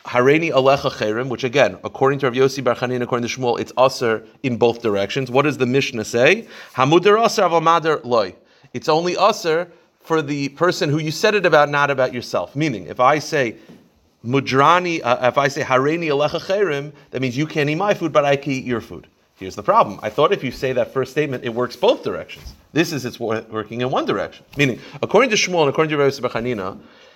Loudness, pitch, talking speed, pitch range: -19 LUFS, 135 Hz, 190 wpm, 125-155 Hz